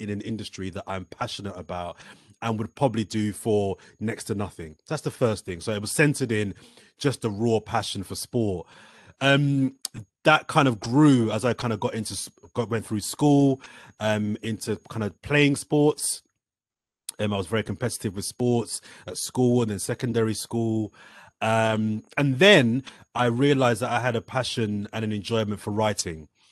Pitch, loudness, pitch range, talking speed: 110 Hz, -25 LUFS, 105-125 Hz, 180 wpm